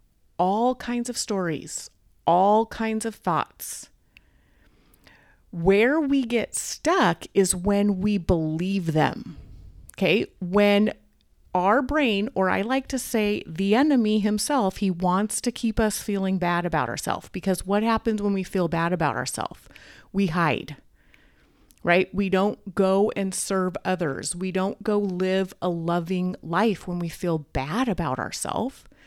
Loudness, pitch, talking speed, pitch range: -24 LUFS, 195 Hz, 140 wpm, 180-215 Hz